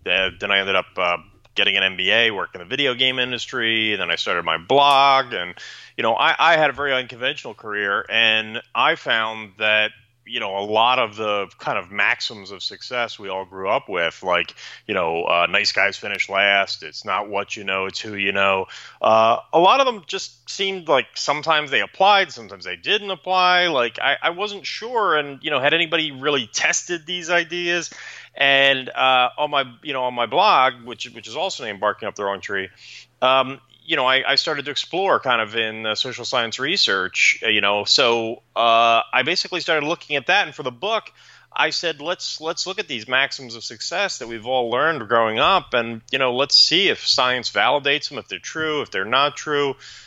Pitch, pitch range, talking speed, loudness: 125 Hz, 110-150 Hz, 210 wpm, -19 LUFS